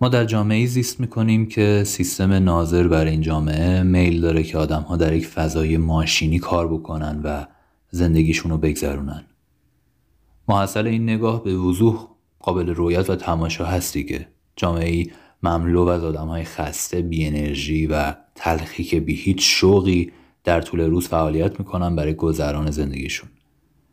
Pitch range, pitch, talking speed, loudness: 80-95 Hz, 85 Hz, 150 wpm, -20 LUFS